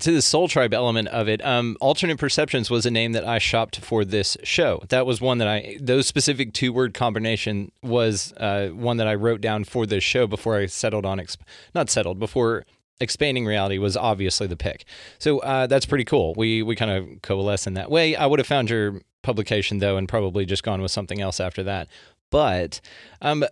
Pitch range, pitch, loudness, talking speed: 100-125 Hz, 110 Hz, -22 LUFS, 215 wpm